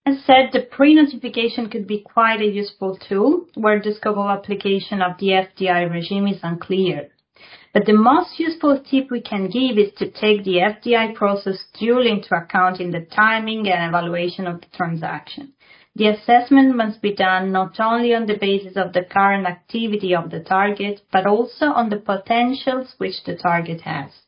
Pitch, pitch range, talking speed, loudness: 205 Hz, 190-235 Hz, 175 wpm, -19 LUFS